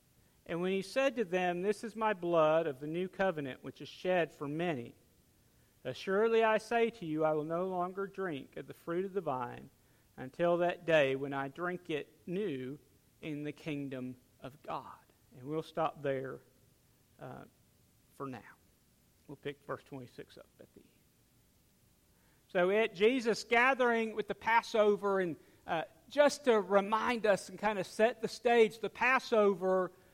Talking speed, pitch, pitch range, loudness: 165 wpm, 180 Hz, 150-215 Hz, -33 LUFS